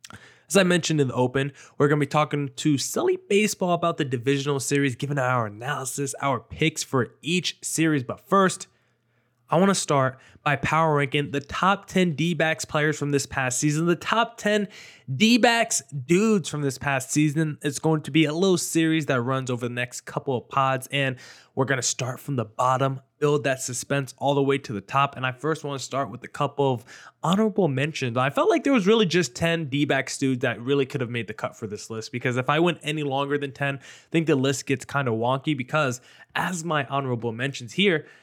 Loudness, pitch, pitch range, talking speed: -24 LUFS, 140 Hz, 130-160 Hz, 220 wpm